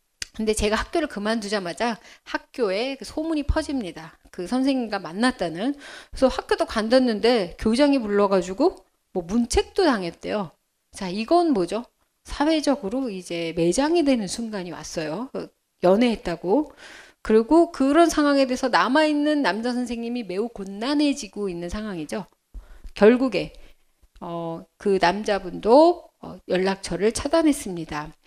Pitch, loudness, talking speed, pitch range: 225 Hz, -23 LUFS, 295 characters per minute, 185-285 Hz